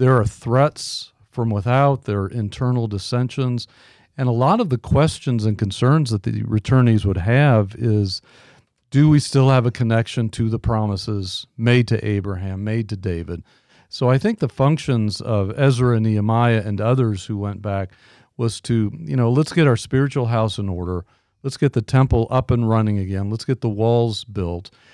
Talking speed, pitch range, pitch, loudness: 185 wpm, 105-130 Hz, 115 Hz, -20 LUFS